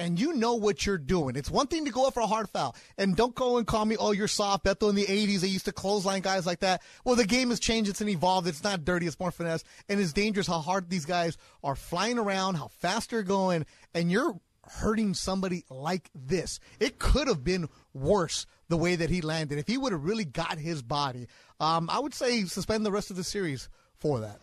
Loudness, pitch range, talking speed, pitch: -29 LUFS, 170-210 Hz, 245 wpm, 190 Hz